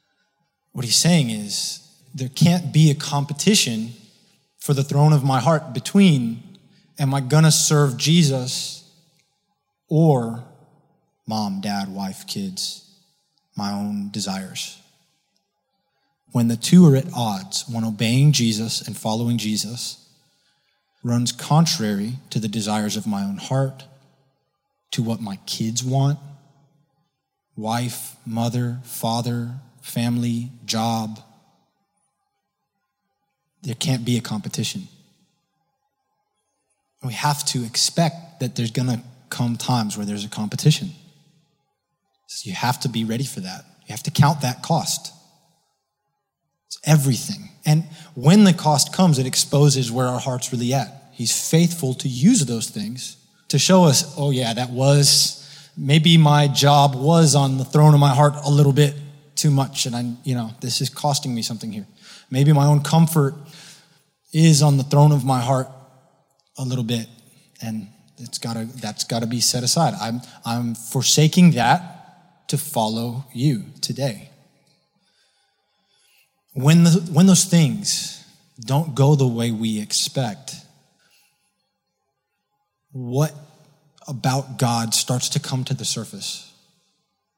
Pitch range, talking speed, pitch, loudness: 120-165 Hz, 135 wpm, 140 Hz, -19 LUFS